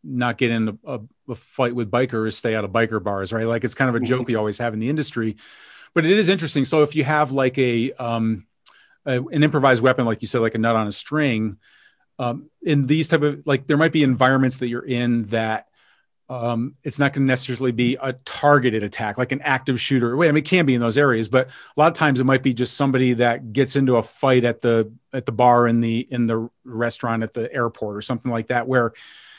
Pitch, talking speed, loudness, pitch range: 125 Hz, 245 wpm, -20 LUFS, 115-135 Hz